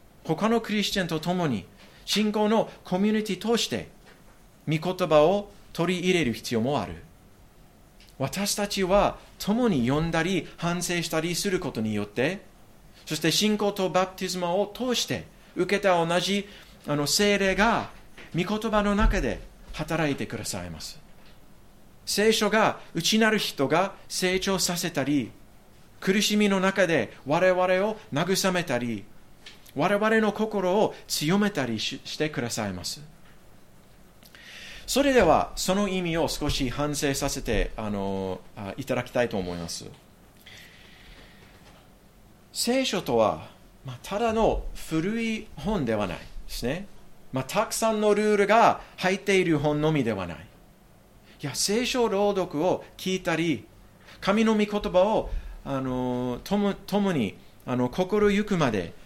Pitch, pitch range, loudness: 180 Hz, 140-205 Hz, -26 LUFS